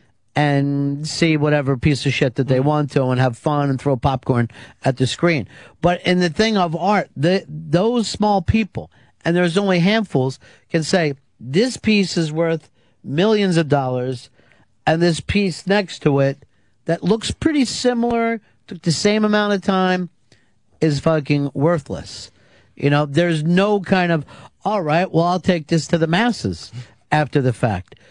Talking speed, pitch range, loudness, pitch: 170 wpm, 135-185 Hz, -19 LUFS, 155 Hz